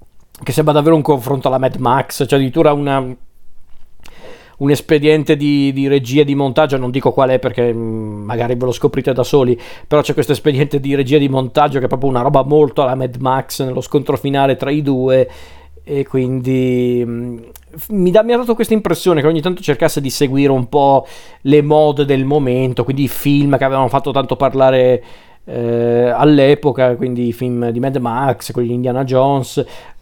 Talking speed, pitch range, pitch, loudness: 185 wpm, 125-145 Hz, 135 Hz, -14 LUFS